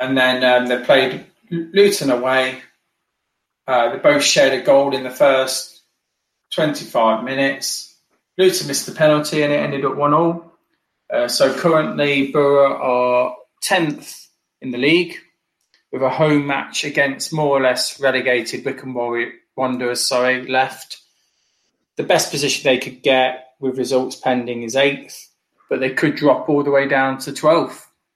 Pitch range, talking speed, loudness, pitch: 130-145 Hz, 150 wpm, -17 LUFS, 135 Hz